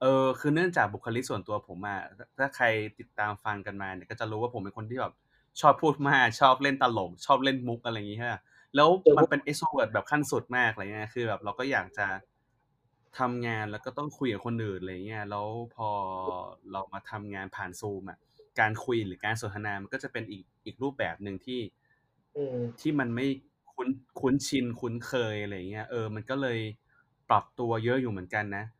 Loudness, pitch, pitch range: -30 LUFS, 115 Hz, 105-130 Hz